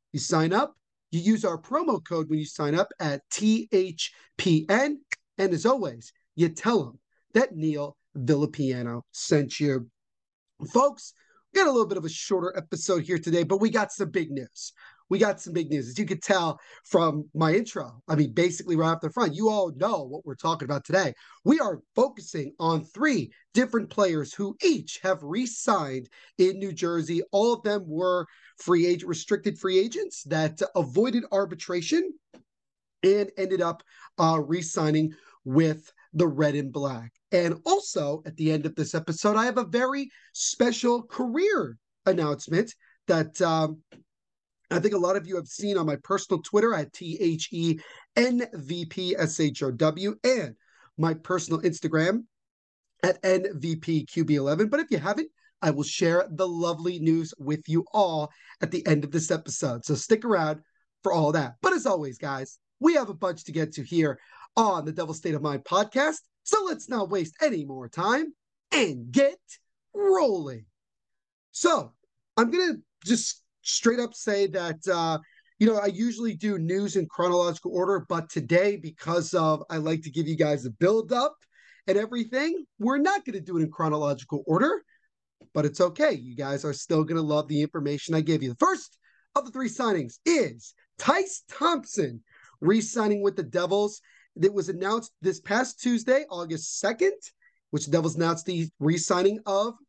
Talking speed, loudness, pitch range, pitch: 170 wpm, -26 LUFS, 155-215 Hz, 180 Hz